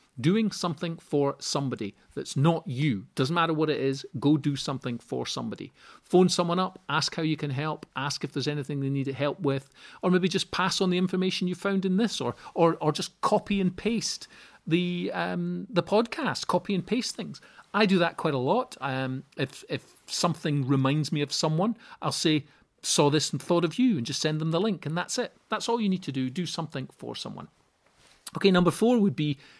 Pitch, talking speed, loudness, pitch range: 165 Hz, 215 wpm, -27 LUFS, 145-185 Hz